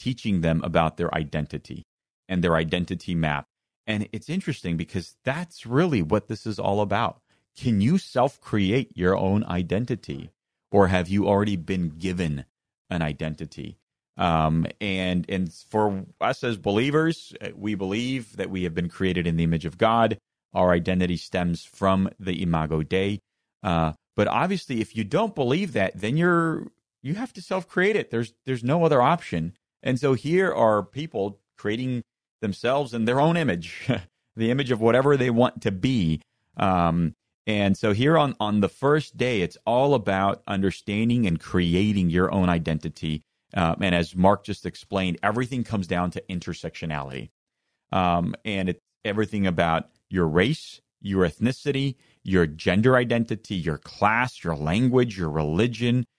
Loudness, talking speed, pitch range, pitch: -25 LUFS, 155 wpm, 90-120 Hz, 100 Hz